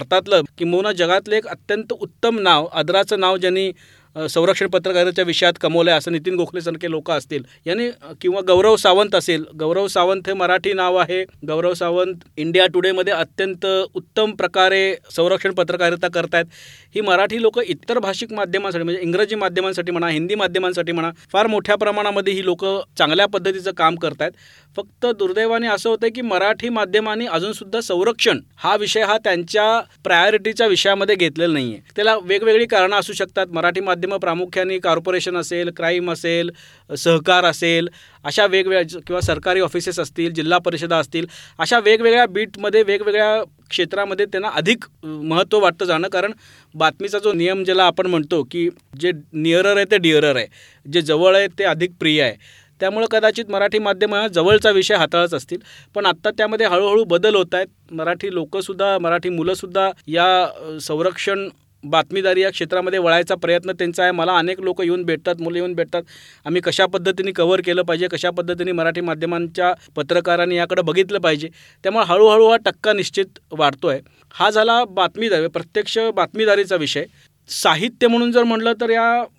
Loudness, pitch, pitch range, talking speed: -18 LUFS, 185 Hz, 170-205 Hz, 155 wpm